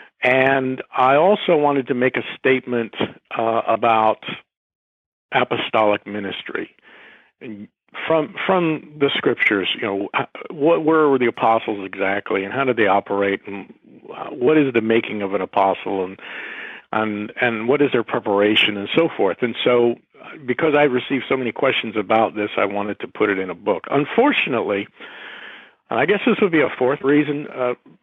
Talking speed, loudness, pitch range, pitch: 165 wpm, -19 LUFS, 105-135 Hz, 120 Hz